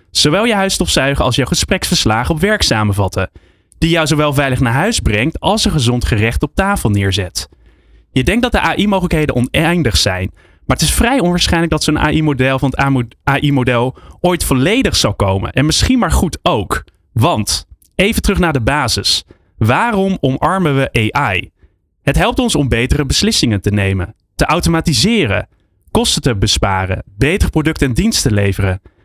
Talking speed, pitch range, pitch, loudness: 165 wpm, 100-165 Hz, 130 Hz, -14 LUFS